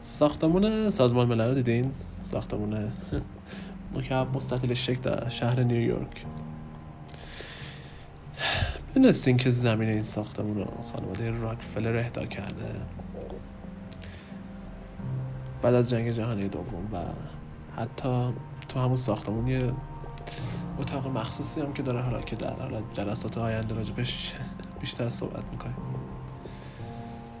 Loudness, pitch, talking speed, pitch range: -29 LUFS, 115 Hz, 105 wpm, 105-130 Hz